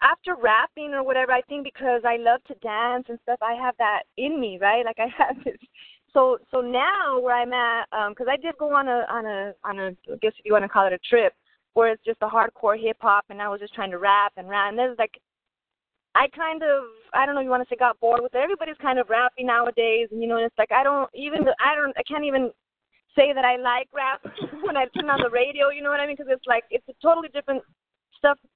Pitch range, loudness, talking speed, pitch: 225-280 Hz, -23 LUFS, 265 wpm, 250 Hz